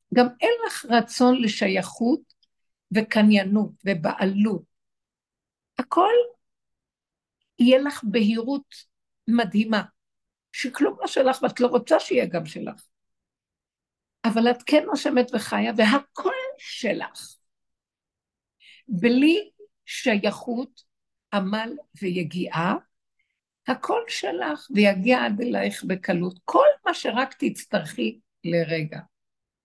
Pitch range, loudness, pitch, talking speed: 200-280 Hz, -23 LUFS, 235 Hz, 85 wpm